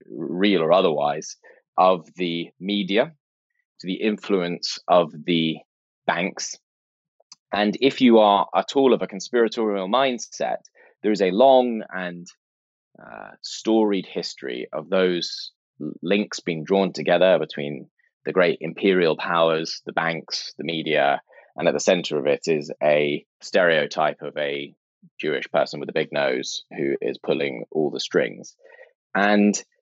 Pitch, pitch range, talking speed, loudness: 95 Hz, 85-110 Hz, 140 wpm, -22 LUFS